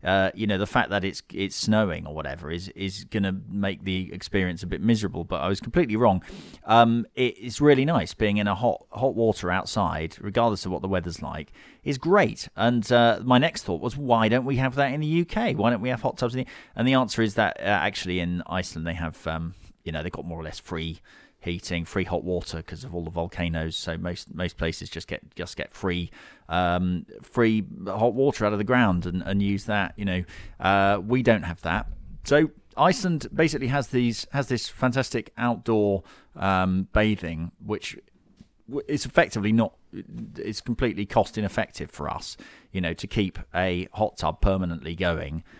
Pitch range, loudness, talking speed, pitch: 90-120 Hz, -25 LUFS, 200 wpm, 100 Hz